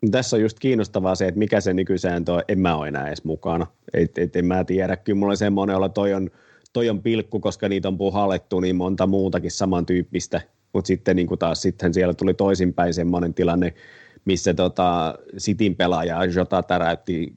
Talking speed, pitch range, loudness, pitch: 195 wpm, 90-100 Hz, -22 LUFS, 95 Hz